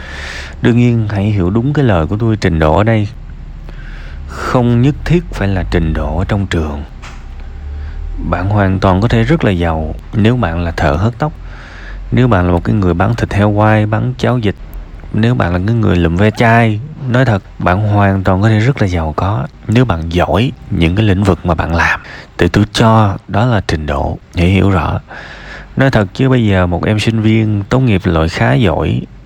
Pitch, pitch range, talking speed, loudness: 100 Hz, 85-115 Hz, 210 wpm, -13 LUFS